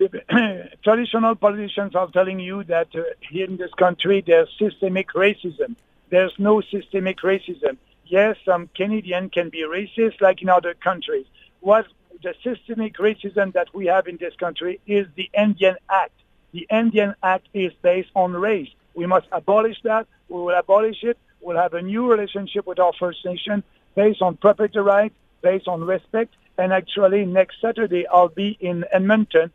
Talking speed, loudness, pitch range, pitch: 165 wpm, -21 LUFS, 180-210 Hz, 190 Hz